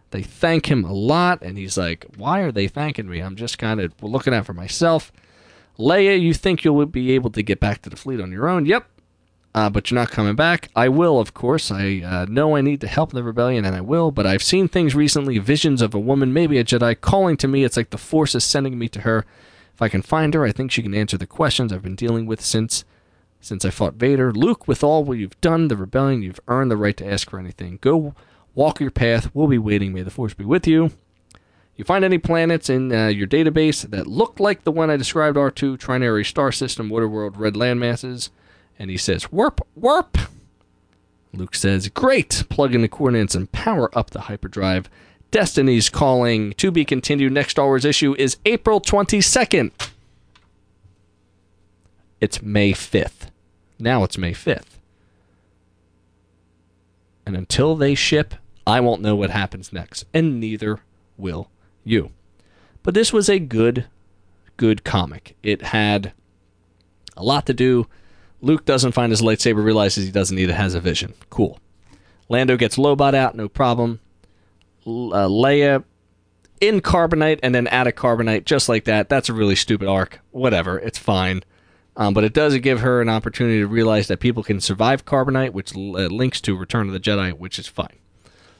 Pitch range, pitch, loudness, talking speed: 95-135 Hz, 110 Hz, -19 LUFS, 195 wpm